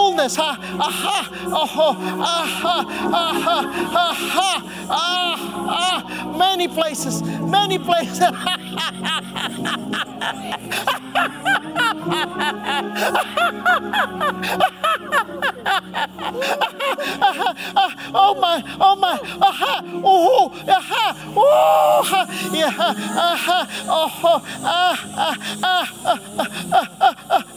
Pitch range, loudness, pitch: 330-385 Hz, -19 LUFS, 360 Hz